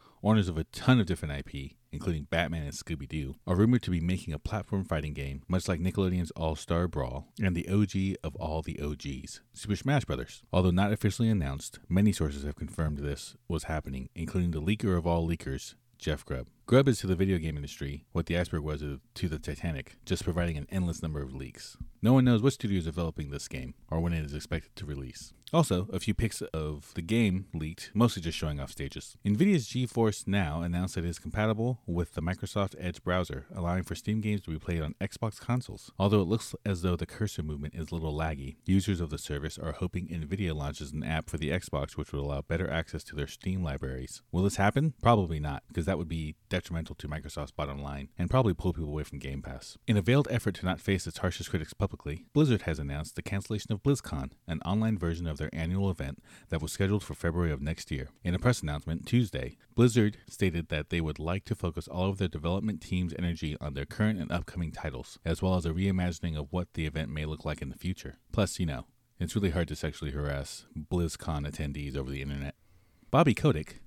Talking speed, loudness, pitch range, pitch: 220 wpm, -32 LUFS, 75-100 Hz, 85 Hz